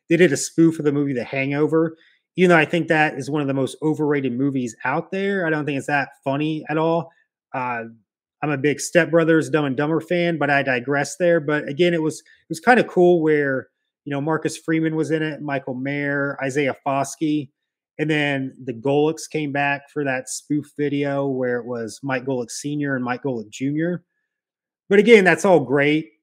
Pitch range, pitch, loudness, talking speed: 140-160 Hz, 145 Hz, -21 LUFS, 210 wpm